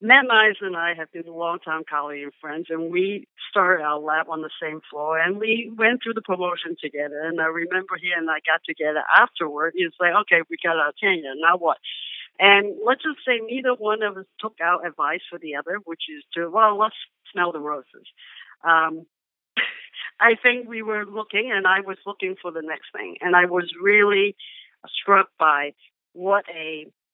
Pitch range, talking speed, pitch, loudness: 160-210 Hz, 200 wpm, 180 Hz, -21 LUFS